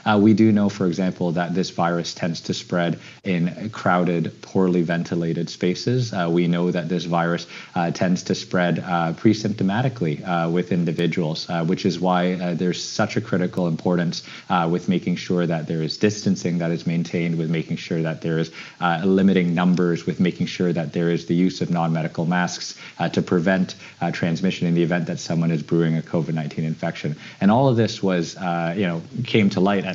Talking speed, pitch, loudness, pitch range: 200 wpm, 85 Hz, -22 LUFS, 85-95 Hz